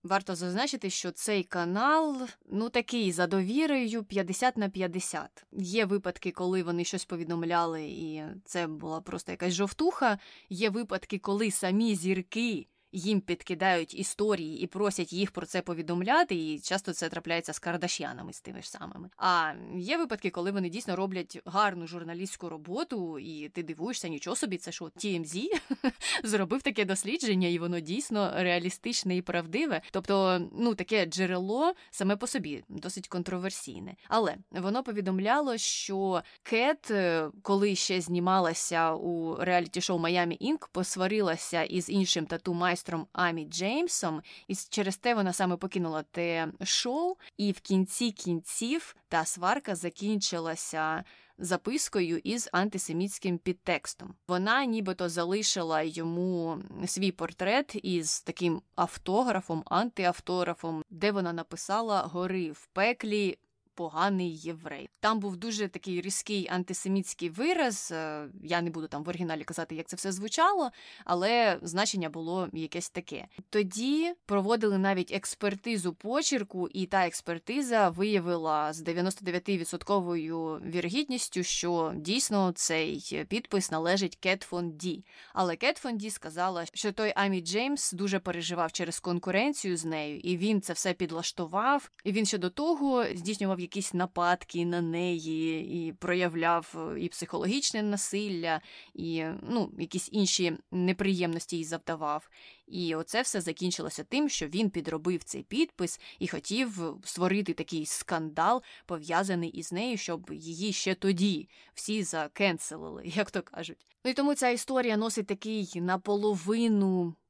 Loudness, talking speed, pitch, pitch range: -31 LUFS, 130 wpm, 185 Hz, 170-205 Hz